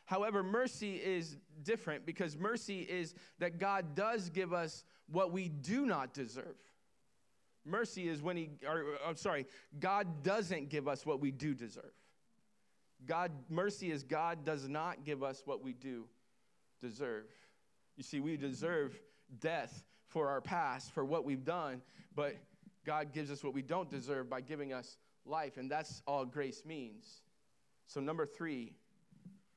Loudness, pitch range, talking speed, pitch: -41 LUFS, 145-190 Hz, 155 wpm, 160 Hz